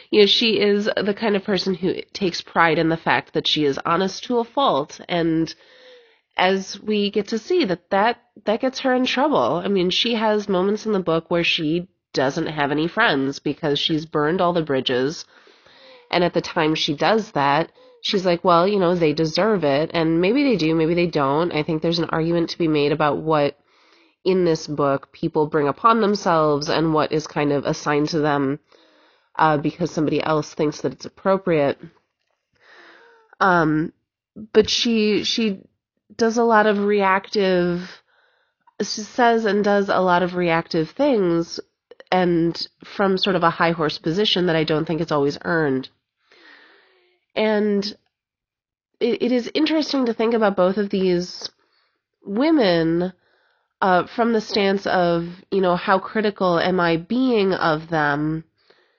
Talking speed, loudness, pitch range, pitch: 170 wpm, -20 LUFS, 160-215 Hz, 180 Hz